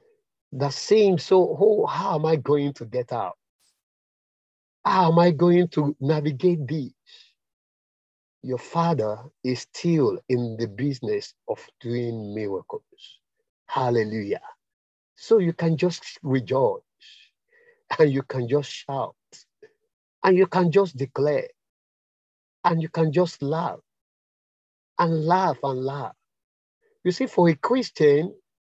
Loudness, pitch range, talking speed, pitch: -23 LUFS, 135-190 Hz, 120 wpm, 160 Hz